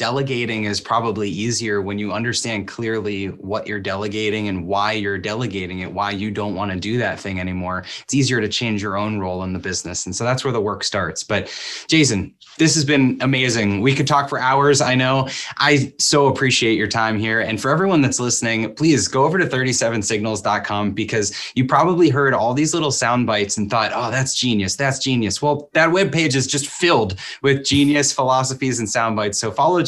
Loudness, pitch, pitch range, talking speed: -19 LUFS, 115 Hz, 105-135 Hz, 205 wpm